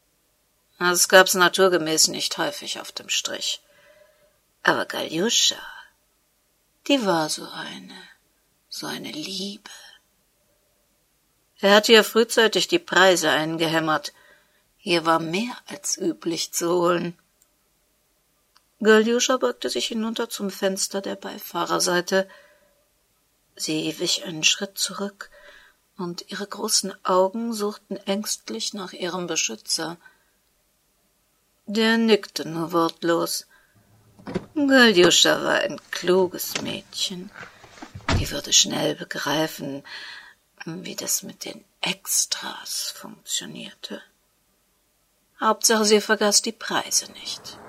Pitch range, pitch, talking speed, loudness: 170-215 Hz, 190 Hz, 100 wpm, -22 LUFS